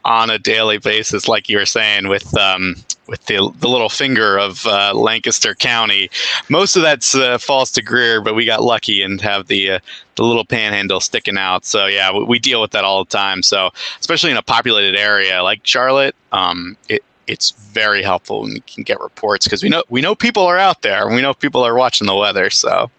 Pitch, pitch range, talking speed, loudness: 105 Hz, 100-125 Hz, 220 wpm, -14 LUFS